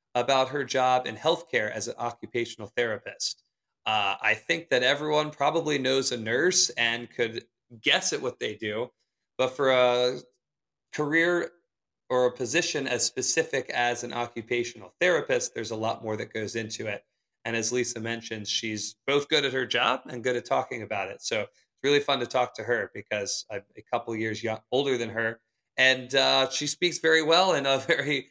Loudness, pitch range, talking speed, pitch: -27 LUFS, 115-140 Hz, 190 wpm, 125 Hz